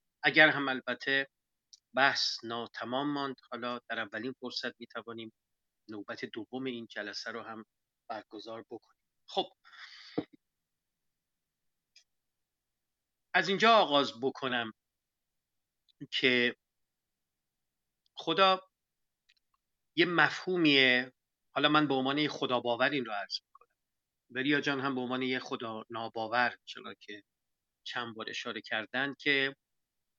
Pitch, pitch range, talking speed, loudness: 125 Hz, 115-140 Hz, 100 wpm, -31 LUFS